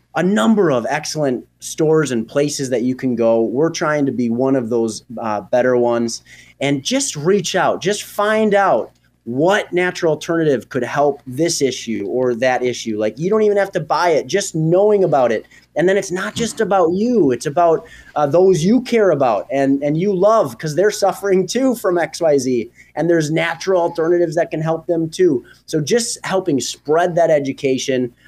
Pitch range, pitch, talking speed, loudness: 130-190 Hz, 160 Hz, 190 wpm, -17 LUFS